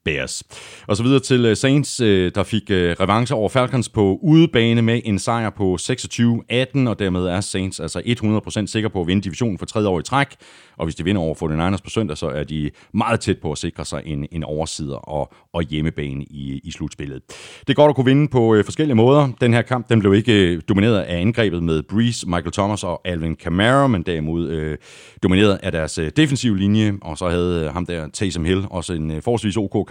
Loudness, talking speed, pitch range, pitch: -19 LUFS, 210 wpm, 85-115 Hz, 100 Hz